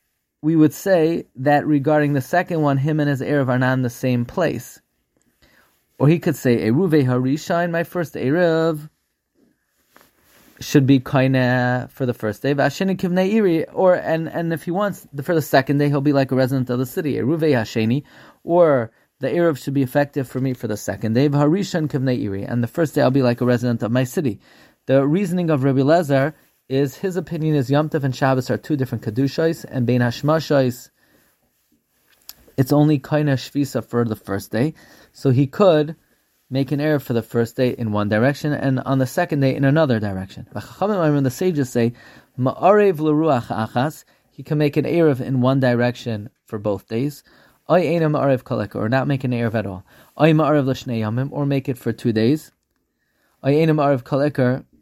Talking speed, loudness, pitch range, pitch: 175 wpm, -19 LUFS, 125-155 Hz, 140 Hz